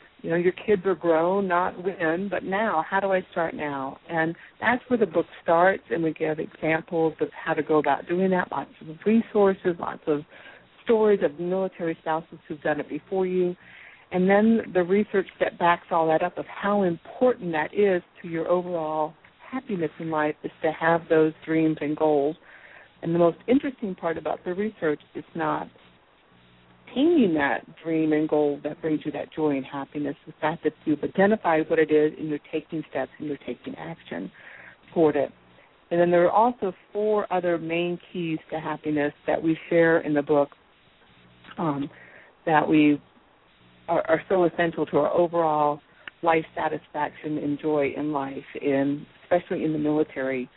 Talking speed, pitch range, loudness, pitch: 180 wpm, 150-180 Hz, -25 LUFS, 165 Hz